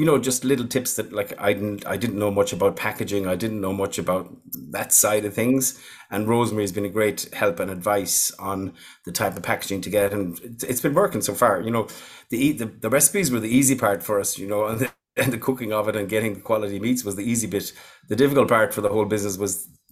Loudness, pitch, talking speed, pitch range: -23 LUFS, 105 Hz, 245 wpm, 100-120 Hz